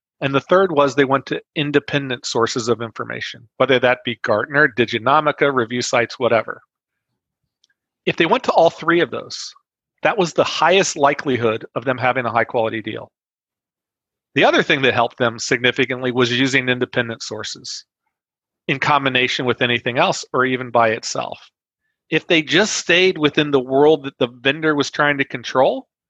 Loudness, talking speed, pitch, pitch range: -18 LUFS, 170 wpm, 135 Hz, 125-150 Hz